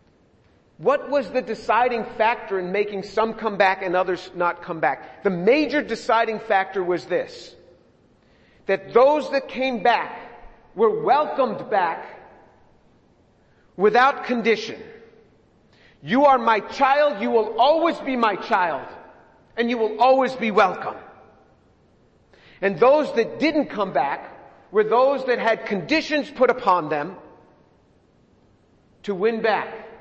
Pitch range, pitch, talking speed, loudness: 200-260 Hz, 225 Hz, 130 wpm, -21 LUFS